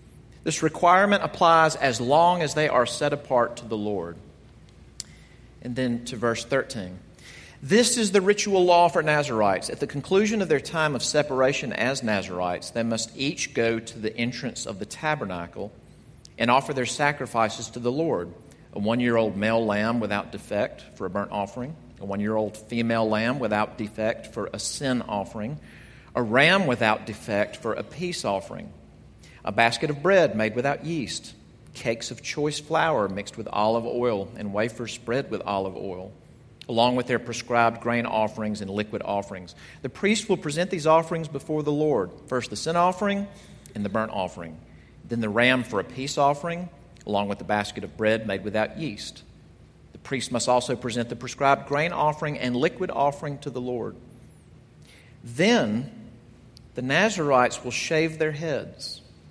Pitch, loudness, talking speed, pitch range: 125 Hz, -25 LUFS, 170 wpm, 110-150 Hz